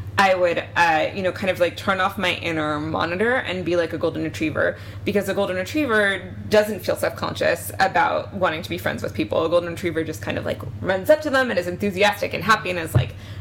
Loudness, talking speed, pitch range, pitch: -22 LUFS, 235 wpm, 160-200 Hz, 180 Hz